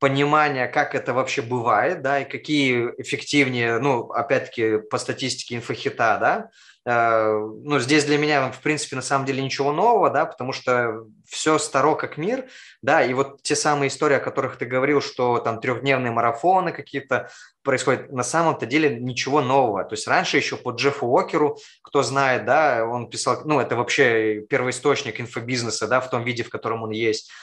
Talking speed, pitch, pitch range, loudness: 175 wpm, 130 Hz, 120-145 Hz, -22 LUFS